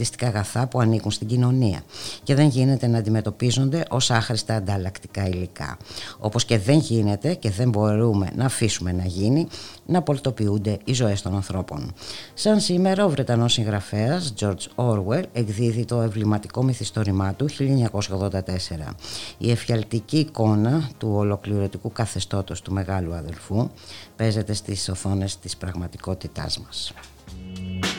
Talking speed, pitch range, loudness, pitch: 125 wpm, 95-125 Hz, -23 LUFS, 110 Hz